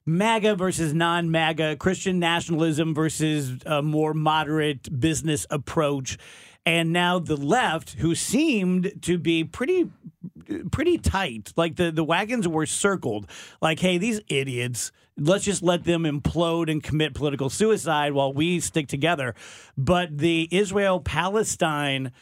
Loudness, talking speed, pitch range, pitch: -24 LUFS, 130 wpm, 150-180 Hz, 165 Hz